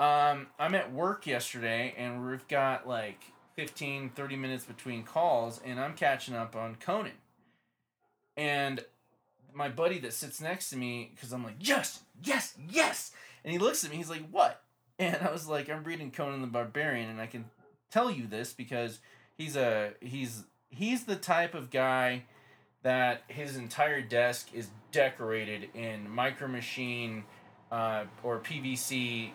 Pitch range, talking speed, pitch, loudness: 120-145 Hz, 160 wpm, 130 Hz, -33 LUFS